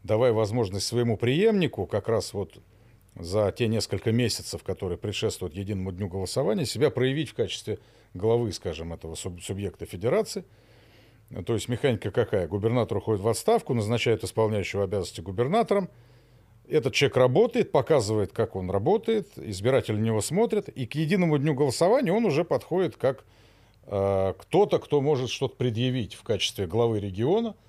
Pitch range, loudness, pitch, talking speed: 100-130 Hz, -26 LUFS, 115 Hz, 145 wpm